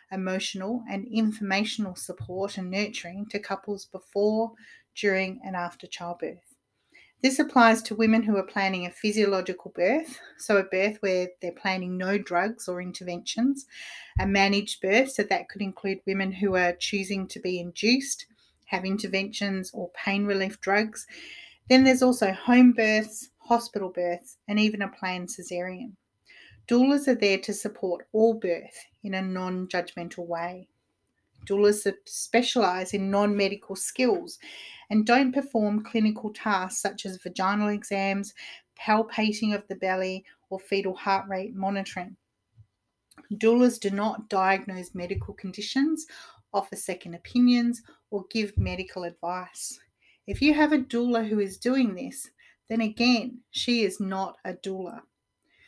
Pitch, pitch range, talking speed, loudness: 200 Hz, 190-225 Hz, 140 wpm, -26 LUFS